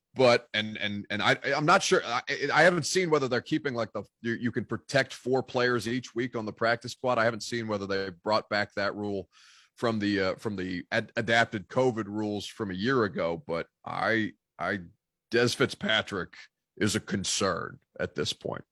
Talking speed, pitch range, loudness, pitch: 200 wpm, 105-125 Hz, -28 LUFS, 115 Hz